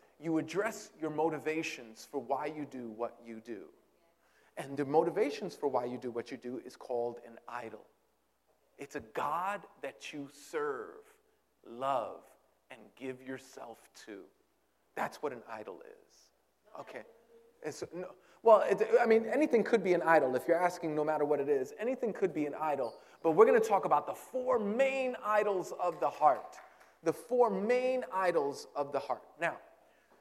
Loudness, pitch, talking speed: -33 LUFS, 175 Hz, 175 wpm